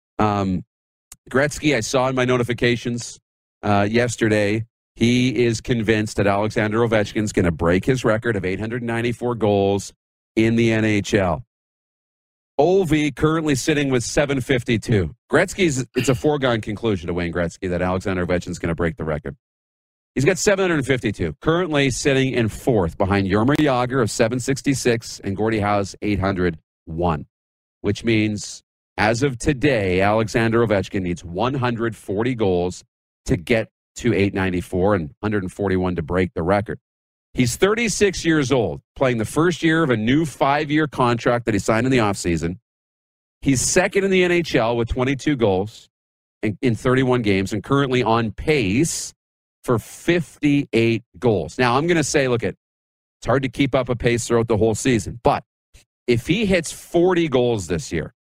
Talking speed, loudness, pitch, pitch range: 150 wpm, -20 LUFS, 115 Hz, 95-130 Hz